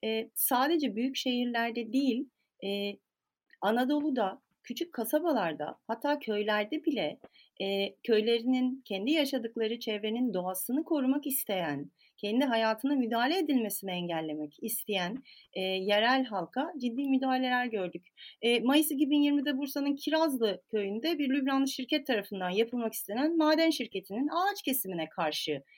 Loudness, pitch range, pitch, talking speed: -31 LUFS, 205-280 Hz, 245 Hz, 115 wpm